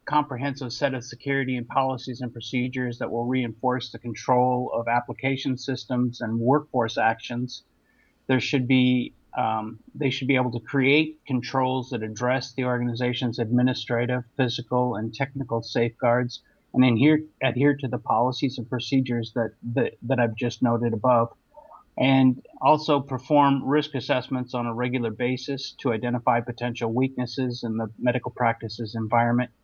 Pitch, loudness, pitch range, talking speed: 125 Hz, -25 LUFS, 120-130 Hz, 150 wpm